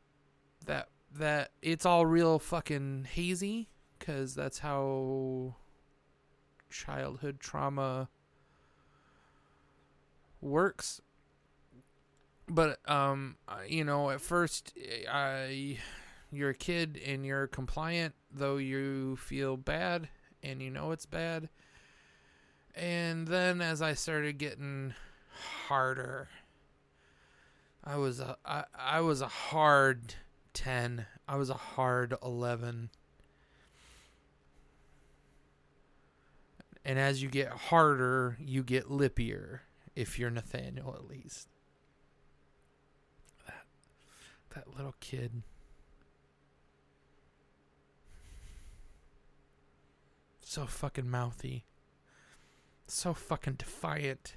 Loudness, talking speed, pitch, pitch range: -34 LUFS, 85 wpm, 135 Hz, 125-150 Hz